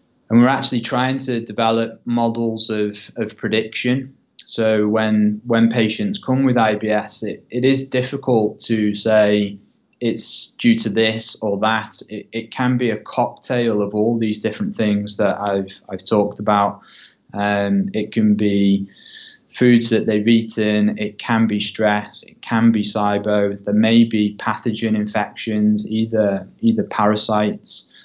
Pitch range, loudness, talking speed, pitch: 105-115 Hz, -19 LUFS, 150 wpm, 110 Hz